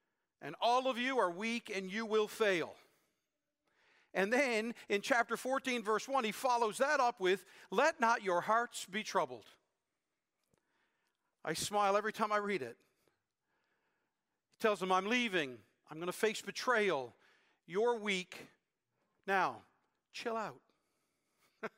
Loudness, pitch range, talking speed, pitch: -35 LUFS, 200-240 Hz, 140 wpm, 220 Hz